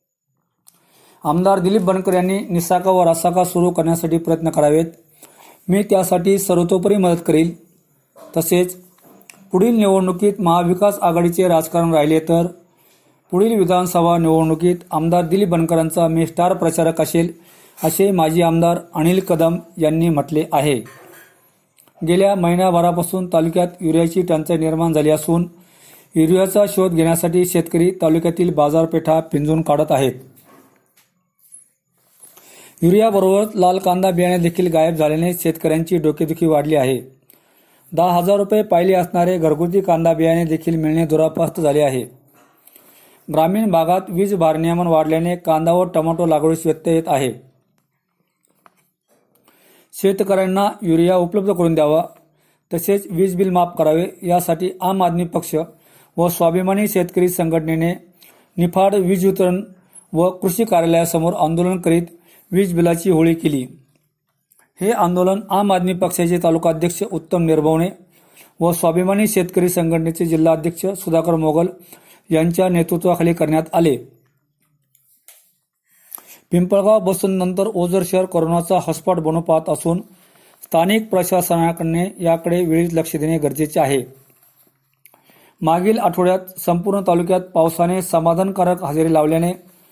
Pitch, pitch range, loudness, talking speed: 170 Hz, 160-185 Hz, -17 LUFS, 115 wpm